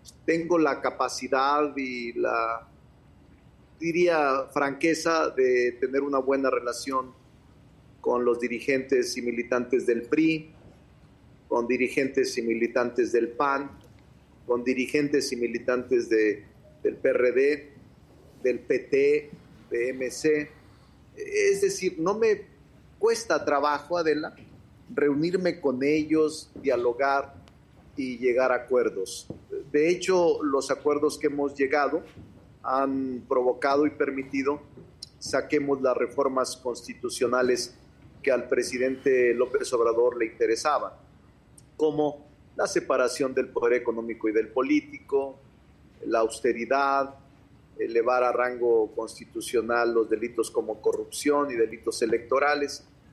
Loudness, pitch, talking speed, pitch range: -26 LUFS, 140 Hz, 105 wpm, 125-165 Hz